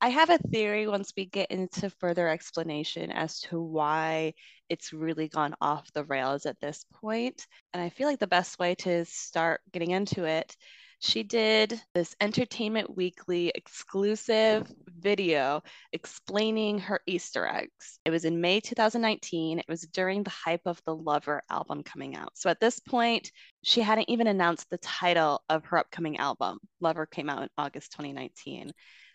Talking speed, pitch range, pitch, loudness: 165 wpm, 160-210 Hz, 175 Hz, -29 LUFS